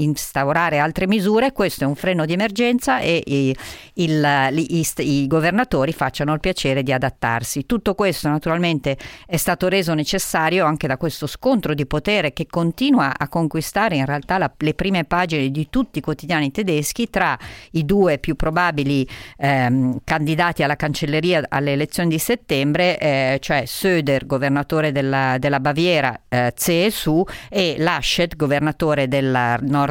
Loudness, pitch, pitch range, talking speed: -19 LUFS, 155 Hz, 140-175 Hz, 155 wpm